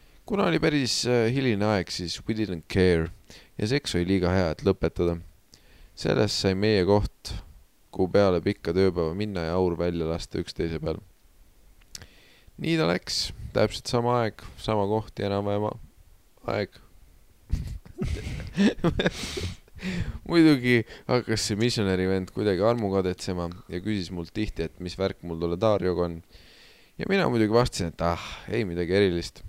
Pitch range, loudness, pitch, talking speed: 85-110 Hz, -26 LUFS, 100 Hz, 140 wpm